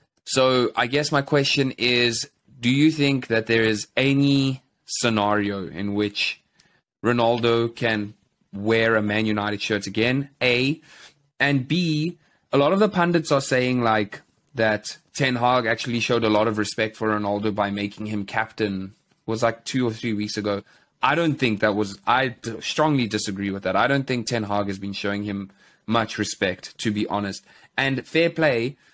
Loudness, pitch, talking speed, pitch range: -22 LUFS, 115 Hz, 175 wpm, 105-135 Hz